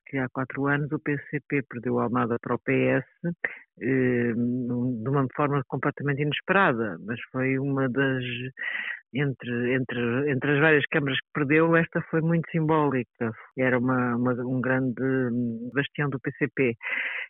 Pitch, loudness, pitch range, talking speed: 130 Hz, -26 LUFS, 125-145 Hz, 140 wpm